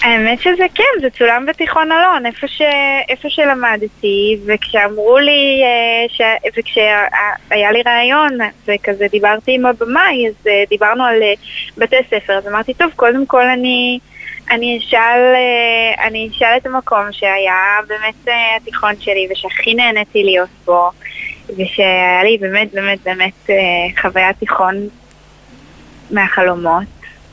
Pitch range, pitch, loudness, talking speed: 205-245 Hz, 225 Hz, -12 LUFS, 115 wpm